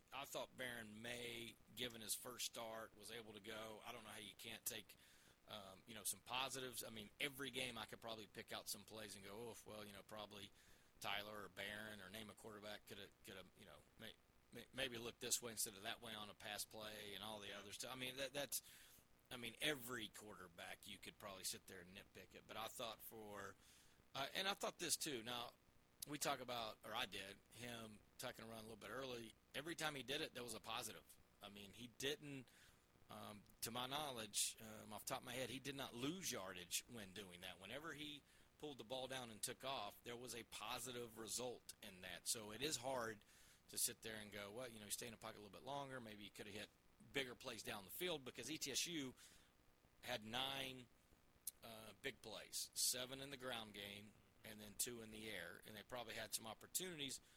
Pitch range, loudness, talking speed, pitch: 105-125 Hz, -50 LUFS, 225 wpm, 110 Hz